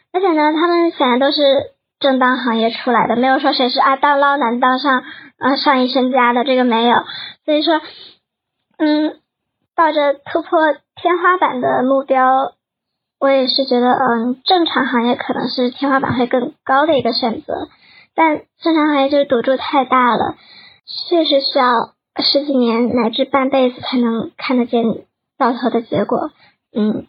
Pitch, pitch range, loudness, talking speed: 265 Hz, 245-295 Hz, -15 LUFS, 250 characters per minute